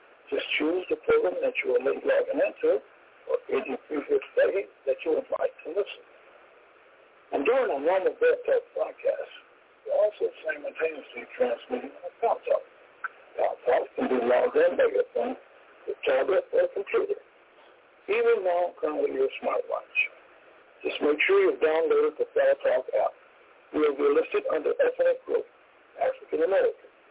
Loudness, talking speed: -27 LUFS, 155 wpm